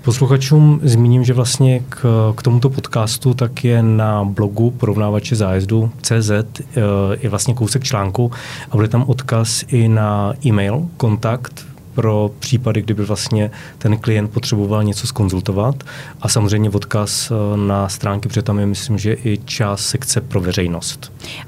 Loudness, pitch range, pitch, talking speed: -16 LUFS, 105-130 Hz, 115 Hz, 140 wpm